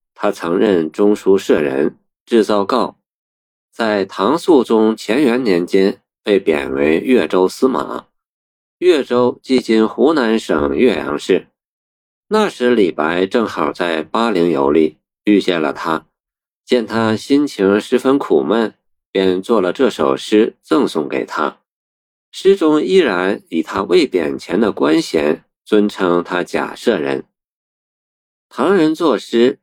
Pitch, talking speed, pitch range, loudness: 105 Hz, 180 characters per minute, 85-125 Hz, -15 LUFS